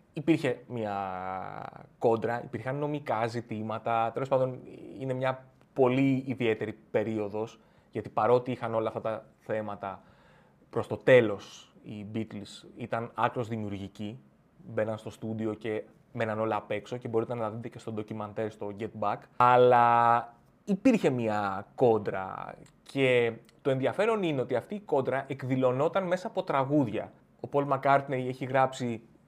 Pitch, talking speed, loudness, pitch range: 120 Hz, 140 wpm, -29 LUFS, 110-130 Hz